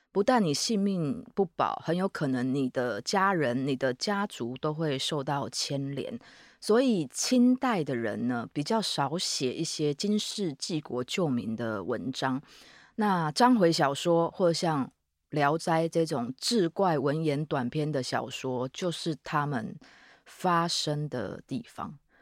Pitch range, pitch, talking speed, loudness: 135-195 Hz, 155 Hz, 210 characters per minute, -29 LUFS